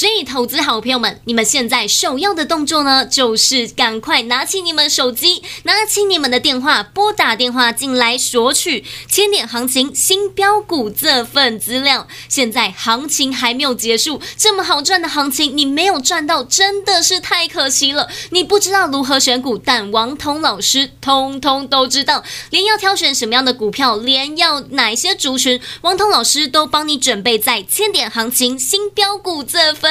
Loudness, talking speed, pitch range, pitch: -13 LUFS, 270 characters per minute, 250-350 Hz, 275 Hz